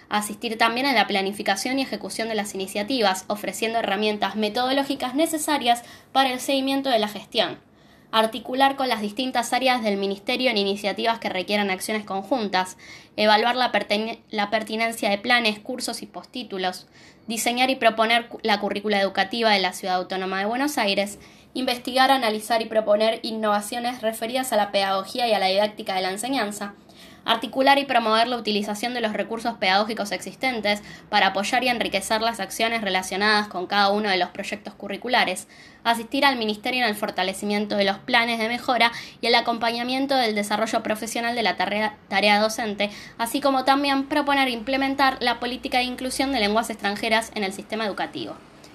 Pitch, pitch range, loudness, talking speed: 220 Hz, 205-245 Hz, -23 LUFS, 165 wpm